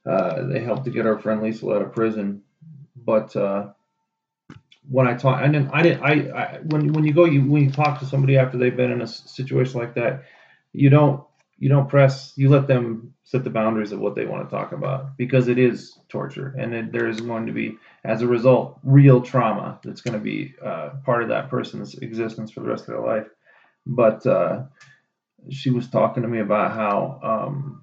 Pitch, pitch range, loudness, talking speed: 130 Hz, 115-140 Hz, -21 LUFS, 220 wpm